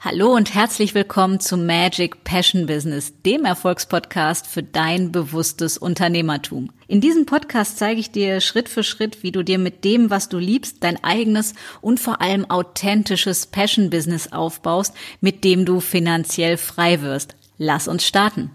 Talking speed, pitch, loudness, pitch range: 160 wpm, 185 Hz, -19 LUFS, 170-210 Hz